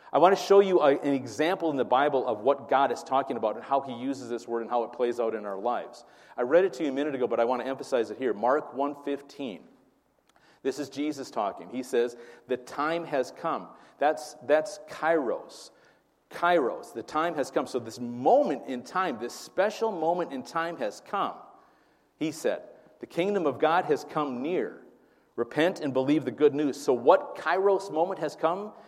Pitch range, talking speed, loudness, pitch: 130-180 Hz, 205 wpm, -28 LUFS, 150 Hz